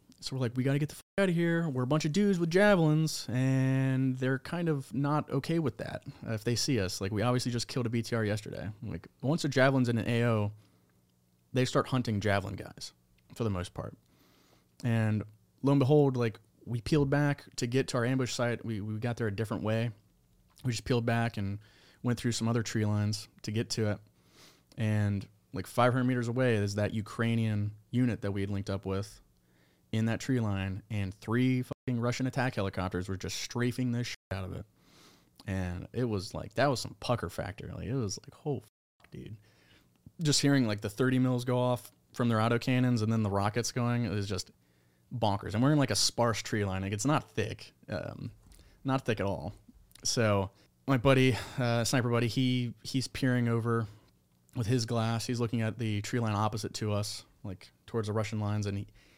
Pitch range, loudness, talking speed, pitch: 105-130 Hz, -31 LUFS, 210 wpm, 115 Hz